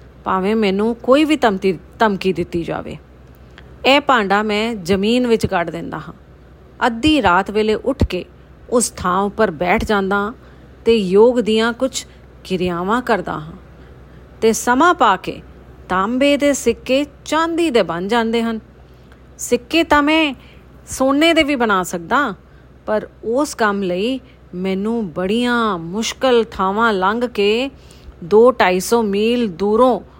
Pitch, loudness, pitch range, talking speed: 220 Hz, -17 LUFS, 185-245 Hz, 130 wpm